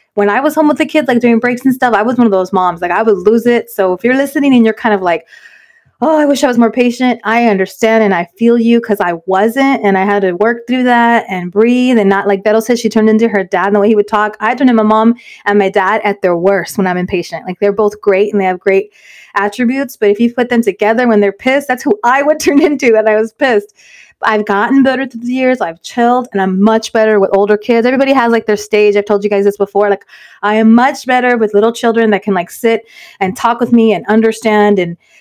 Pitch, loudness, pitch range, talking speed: 220 Hz, -11 LUFS, 200-245 Hz, 275 wpm